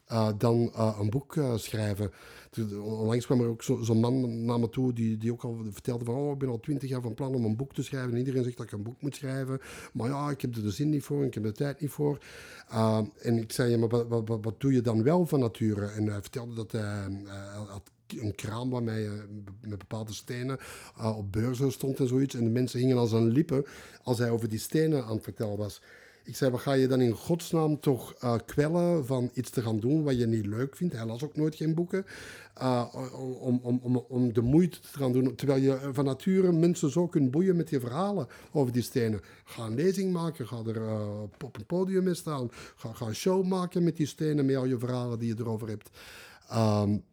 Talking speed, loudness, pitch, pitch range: 245 wpm, -30 LUFS, 125 Hz, 115-140 Hz